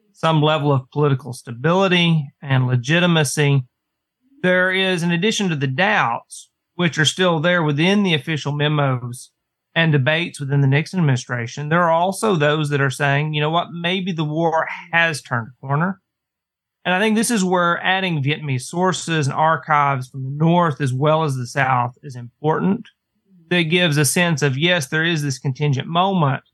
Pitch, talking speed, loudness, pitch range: 155 Hz, 175 wpm, -18 LUFS, 140-175 Hz